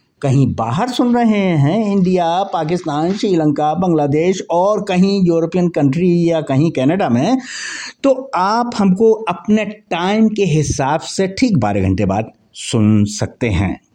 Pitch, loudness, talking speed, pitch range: 175 Hz, -15 LUFS, 140 wpm, 150-205 Hz